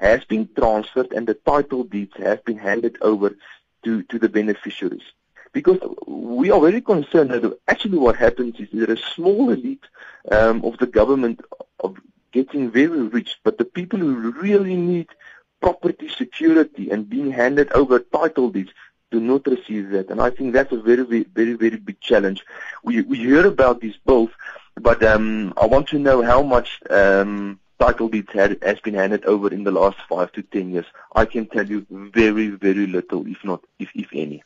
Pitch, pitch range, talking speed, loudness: 115 Hz, 105-140 Hz, 185 wpm, -19 LUFS